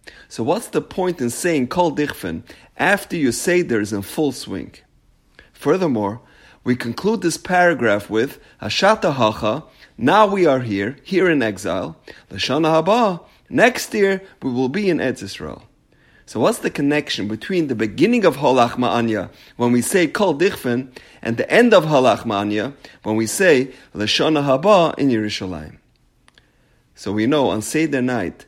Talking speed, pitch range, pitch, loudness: 150 wpm, 110-170 Hz, 130 Hz, -18 LUFS